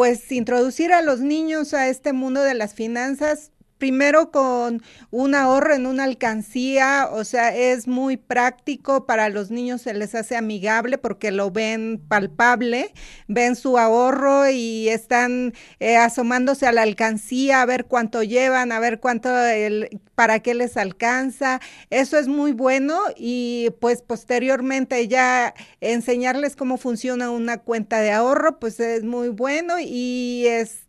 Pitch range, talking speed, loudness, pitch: 230-265 Hz, 150 wpm, -20 LUFS, 245 Hz